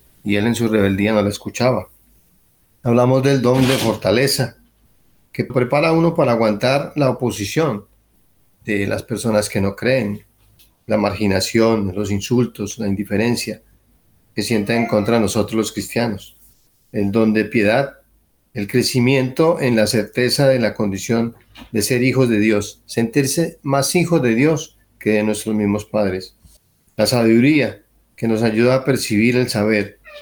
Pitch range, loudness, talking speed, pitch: 105-125 Hz, -18 LUFS, 150 wpm, 110 Hz